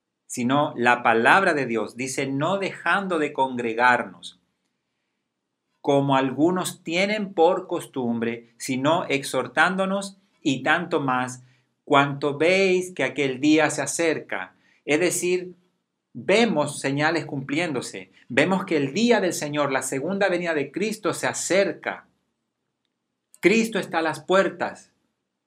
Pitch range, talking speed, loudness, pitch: 130-180 Hz, 120 wpm, -23 LUFS, 150 Hz